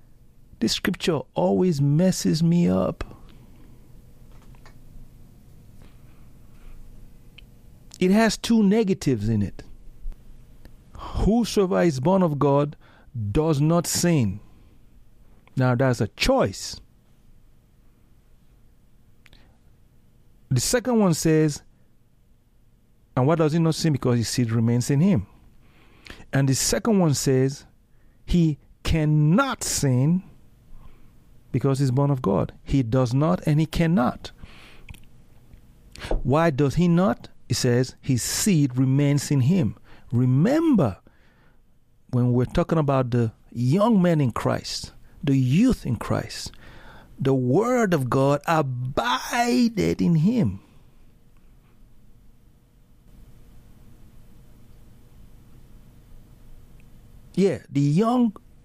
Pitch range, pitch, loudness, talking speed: 120-170 Hz, 135 Hz, -22 LUFS, 95 wpm